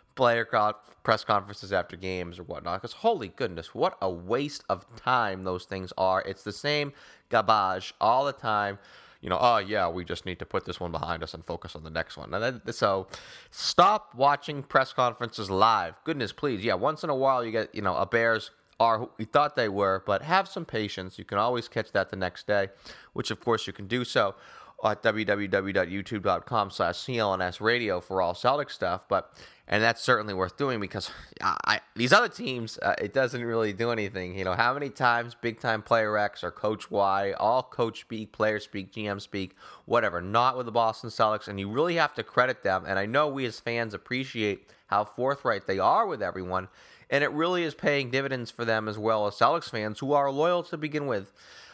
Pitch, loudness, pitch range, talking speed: 110 Hz, -28 LUFS, 95-125 Hz, 205 wpm